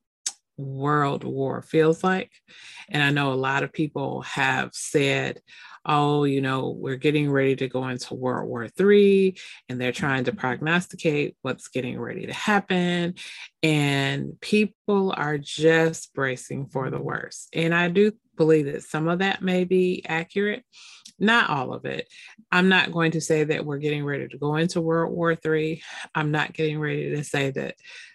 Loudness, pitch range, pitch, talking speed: -24 LUFS, 140-185 Hz, 155 Hz, 170 wpm